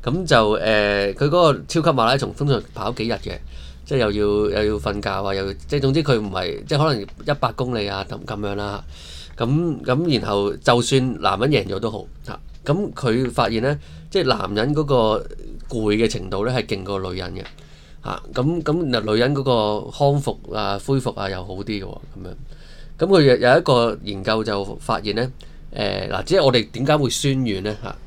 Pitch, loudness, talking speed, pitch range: 110 Hz, -20 LUFS, 285 characters per minute, 100-135 Hz